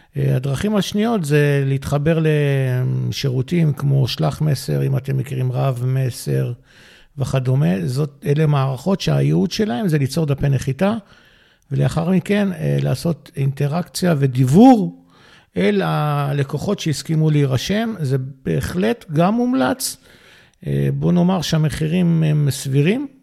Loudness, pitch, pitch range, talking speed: -18 LUFS, 145 Hz, 135-175 Hz, 105 wpm